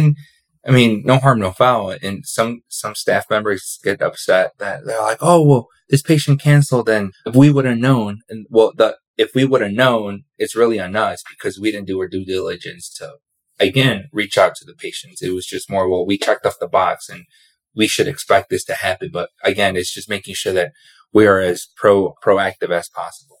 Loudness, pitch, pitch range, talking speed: -17 LUFS, 110 Hz, 100-135 Hz, 215 wpm